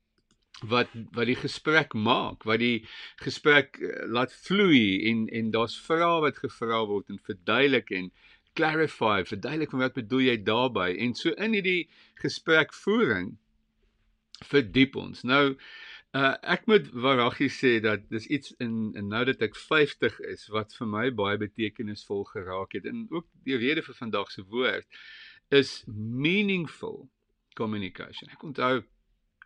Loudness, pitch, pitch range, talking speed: -27 LUFS, 120 Hz, 110-140 Hz, 145 wpm